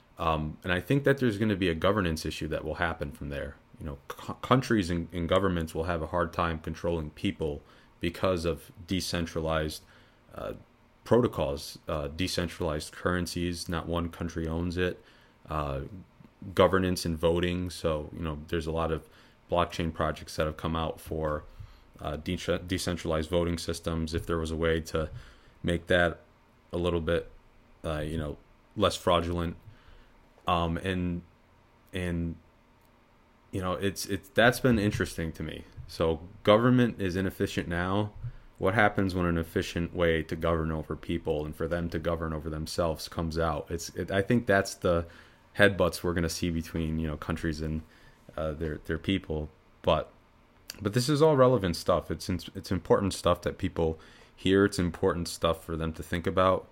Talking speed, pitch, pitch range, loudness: 170 wpm, 85 Hz, 80-95 Hz, -30 LUFS